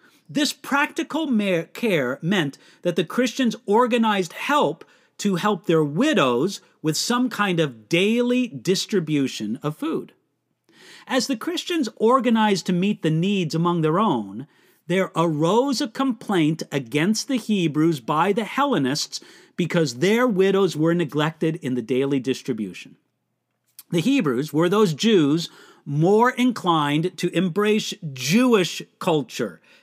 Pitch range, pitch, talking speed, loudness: 160-240 Hz, 190 Hz, 125 wpm, -22 LUFS